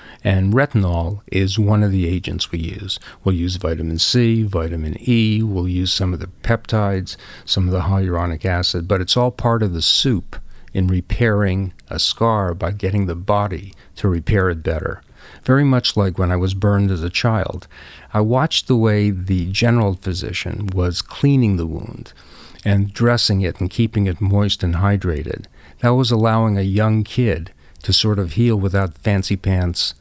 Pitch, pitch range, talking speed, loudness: 95 Hz, 90-110 Hz, 175 wpm, -18 LUFS